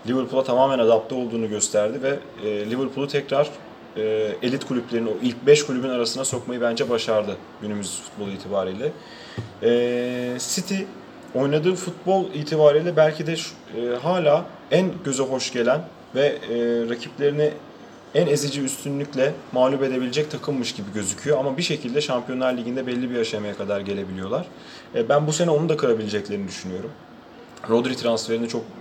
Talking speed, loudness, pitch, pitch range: 140 wpm, -23 LUFS, 125 Hz, 115-145 Hz